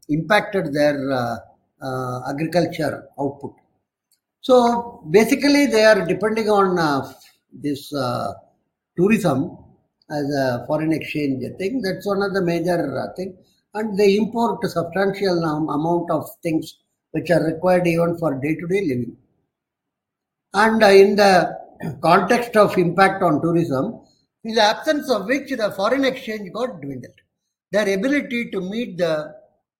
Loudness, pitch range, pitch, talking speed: -19 LUFS, 155-210 Hz, 180 Hz, 135 wpm